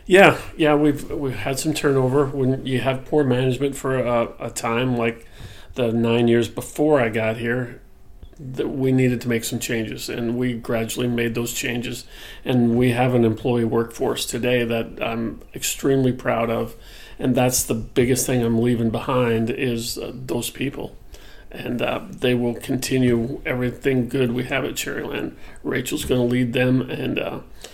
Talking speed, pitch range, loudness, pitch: 170 wpm, 115-130 Hz, -21 LUFS, 125 Hz